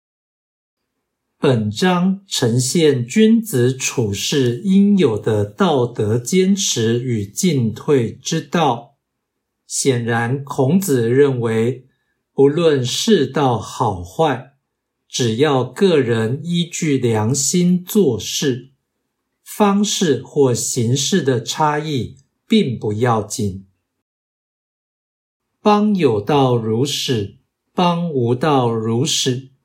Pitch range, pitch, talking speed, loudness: 120-165 Hz, 135 Hz, 130 characters per minute, -17 LUFS